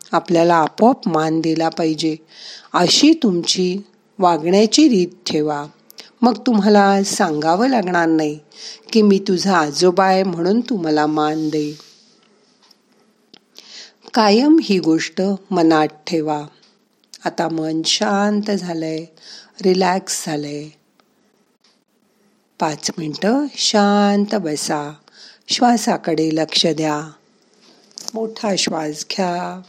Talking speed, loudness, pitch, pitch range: 90 wpm, -17 LUFS, 190 Hz, 160-215 Hz